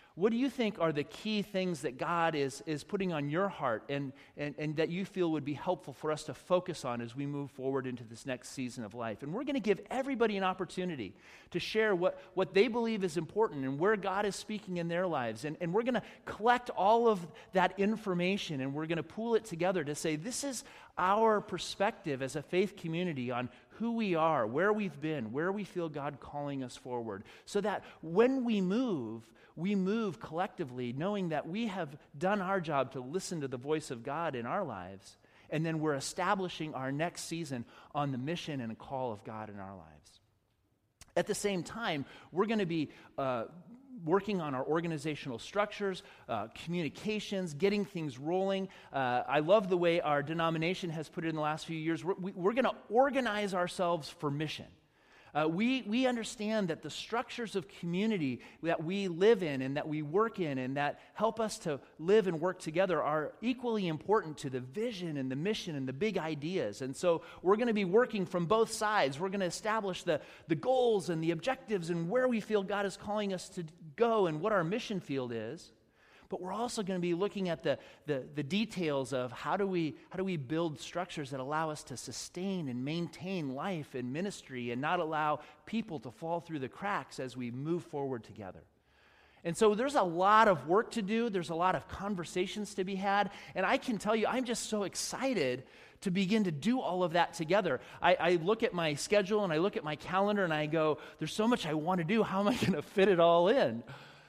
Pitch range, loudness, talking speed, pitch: 150-205 Hz, -34 LUFS, 215 wpm, 175 Hz